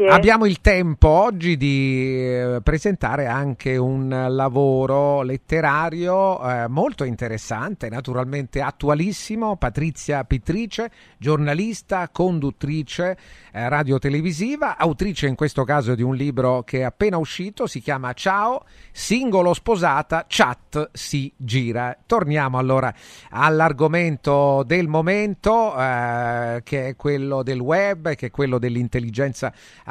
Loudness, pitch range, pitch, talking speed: -21 LUFS, 130-175 Hz, 140 Hz, 105 wpm